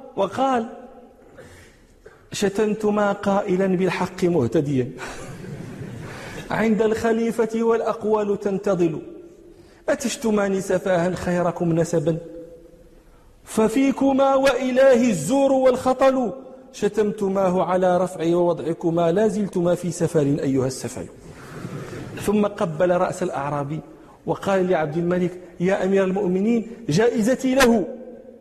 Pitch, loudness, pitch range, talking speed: 195 Hz, -21 LUFS, 170-230 Hz, 80 wpm